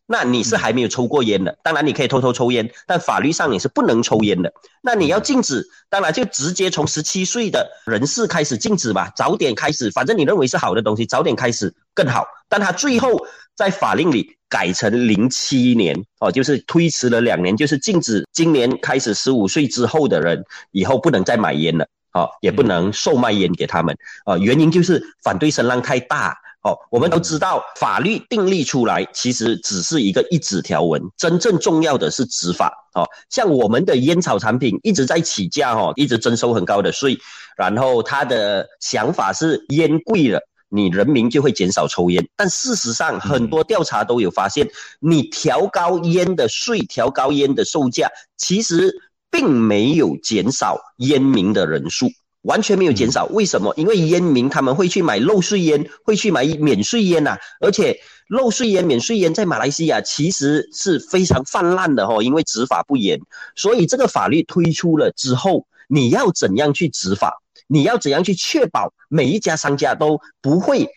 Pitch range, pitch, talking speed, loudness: 130-195 Hz, 160 Hz, 285 characters per minute, -17 LUFS